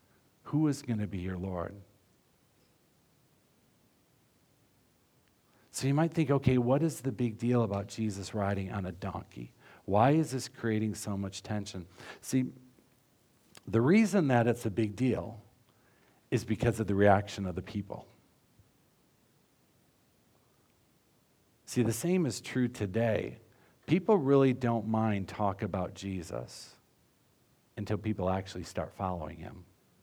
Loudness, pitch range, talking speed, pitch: -31 LUFS, 100-125 Hz, 130 wpm, 110 Hz